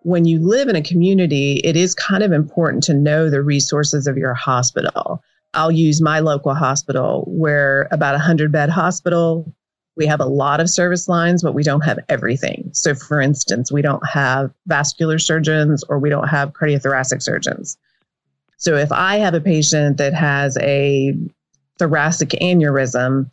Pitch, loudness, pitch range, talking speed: 150 Hz, -16 LUFS, 140-165 Hz, 170 wpm